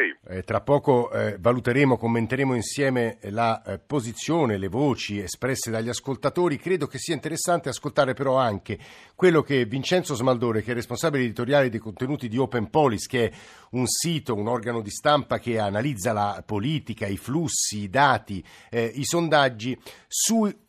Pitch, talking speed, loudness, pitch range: 125 Hz, 160 wpm, -24 LUFS, 110-145 Hz